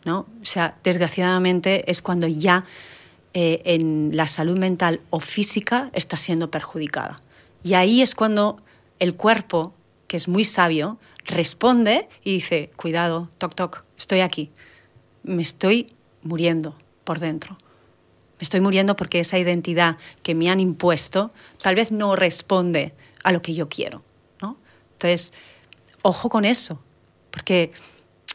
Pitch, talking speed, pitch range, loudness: 175 Hz, 140 wpm, 165-190 Hz, -21 LUFS